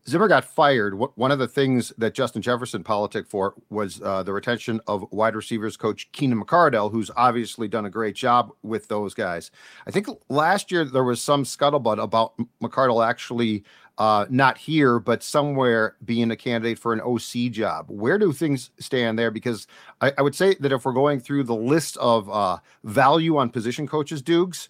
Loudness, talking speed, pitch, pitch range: -23 LUFS, 190 wpm, 120 Hz, 110-135 Hz